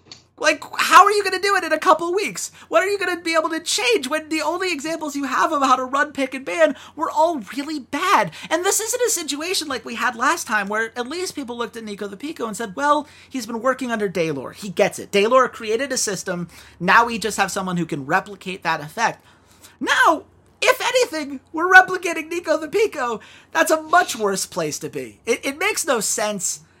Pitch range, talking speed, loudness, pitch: 220-330 Hz, 230 wpm, -20 LUFS, 280 Hz